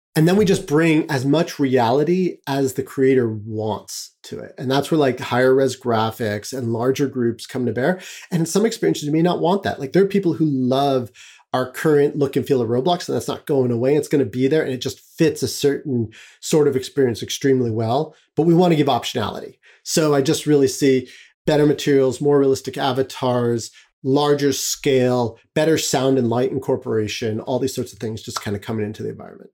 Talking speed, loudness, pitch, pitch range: 215 wpm, -20 LUFS, 135 Hz, 125-150 Hz